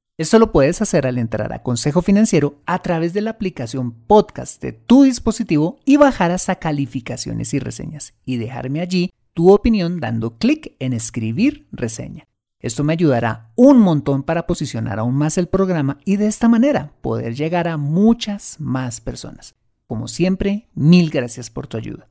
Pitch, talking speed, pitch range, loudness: 160 Hz, 170 wpm, 125-200 Hz, -17 LUFS